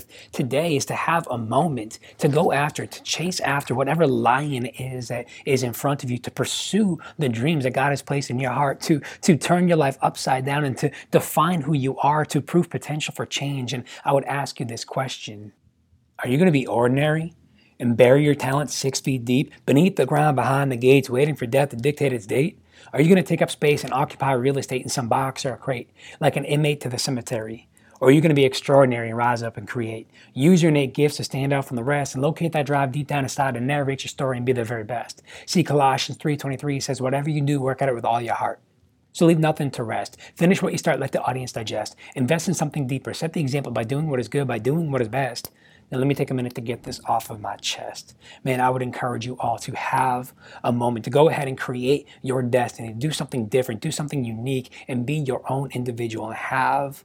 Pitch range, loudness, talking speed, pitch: 125-145 Hz, -22 LUFS, 240 wpm, 135 Hz